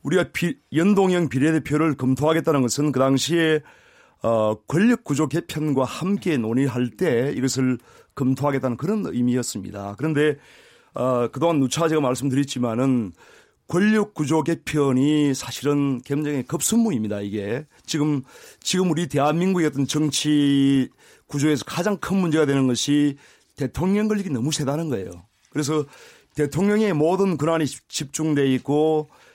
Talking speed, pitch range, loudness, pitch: 315 characters per minute, 130-160 Hz, -22 LUFS, 145 Hz